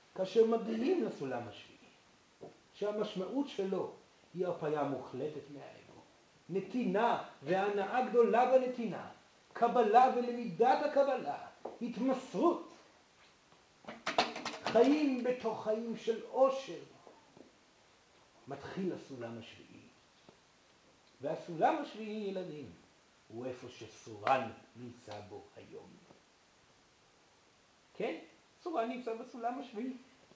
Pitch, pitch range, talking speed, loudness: 225 Hz, 185-250 Hz, 80 wpm, -35 LUFS